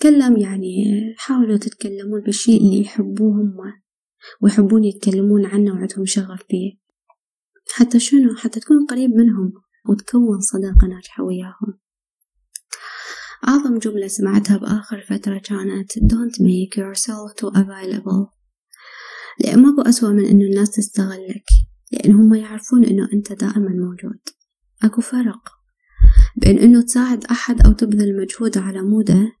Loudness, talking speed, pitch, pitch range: -16 LUFS, 120 wpm, 210 Hz, 200-230 Hz